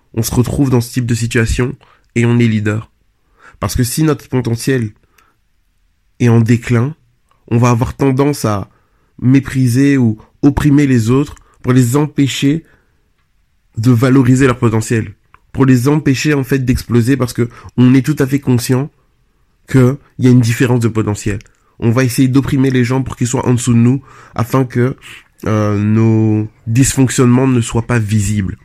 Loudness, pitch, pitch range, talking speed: -13 LUFS, 125 Hz, 110-135 Hz, 170 wpm